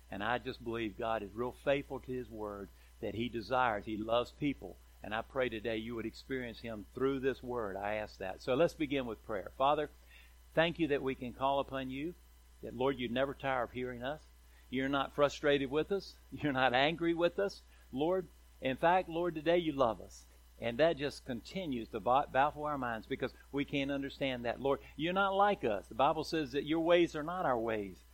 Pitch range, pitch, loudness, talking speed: 115-145 Hz, 130 Hz, -35 LUFS, 210 wpm